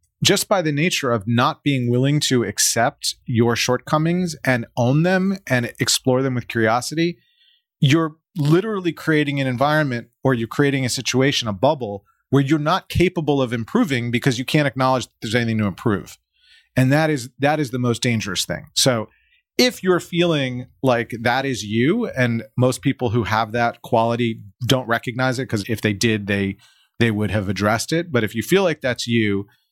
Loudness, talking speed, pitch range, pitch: -20 LUFS, 185 wpm, 115-150 Hz, 130 Hz